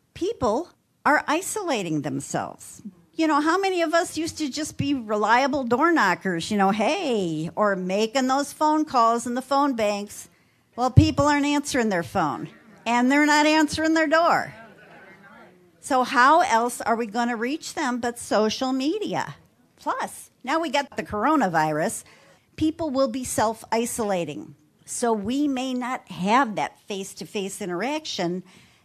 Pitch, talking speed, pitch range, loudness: 250 Hz, 155 wpm, 210-295 Hz, -23 LUFS